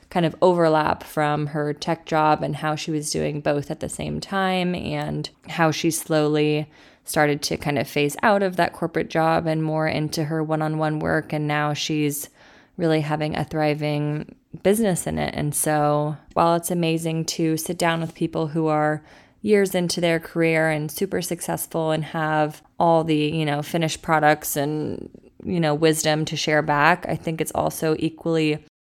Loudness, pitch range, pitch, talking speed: -22 LUFS, 150-165 Hz, 155 Hz, 180 wpm